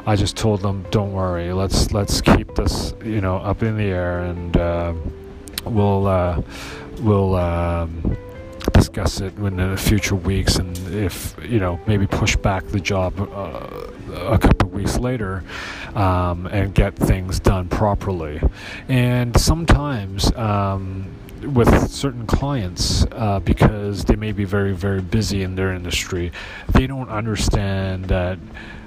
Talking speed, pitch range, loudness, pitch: 145 wpm, 90-105 Hz, -20 LUFS, 95 Hz